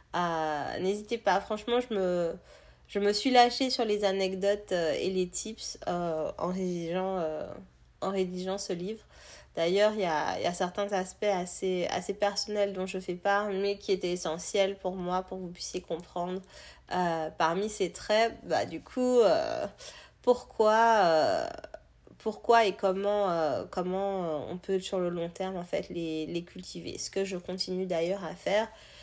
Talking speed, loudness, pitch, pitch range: 175 wpm, -30 LUFS, 190 Hz, 175-205 Hz